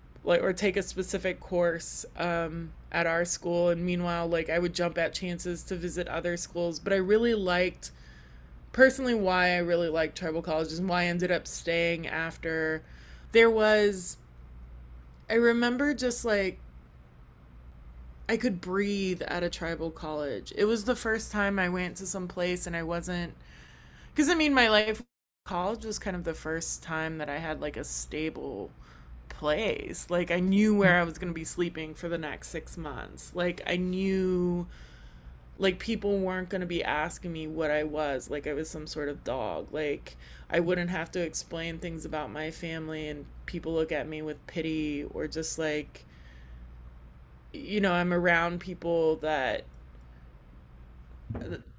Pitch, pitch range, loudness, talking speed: 170 Hz, 150-180 Hz, -29 LUFS, 170 wpm